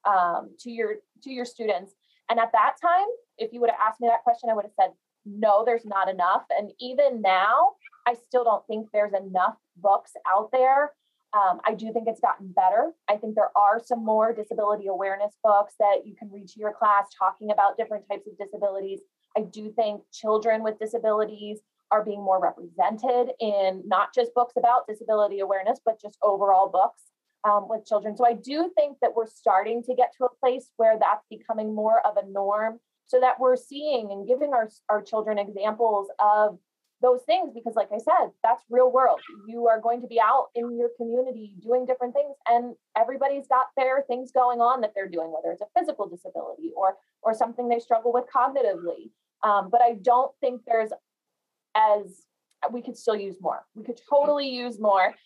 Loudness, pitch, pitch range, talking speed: -25 LUFS, 225 Hz, 210-250 Hz, 195 wpm